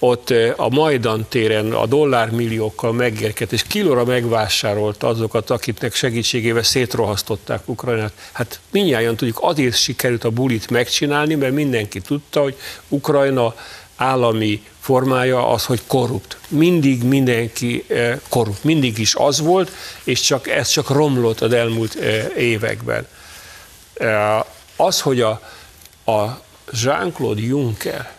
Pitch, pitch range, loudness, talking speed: 120 Hz, 110-130 Hz, -18 LUFS, 115 wpm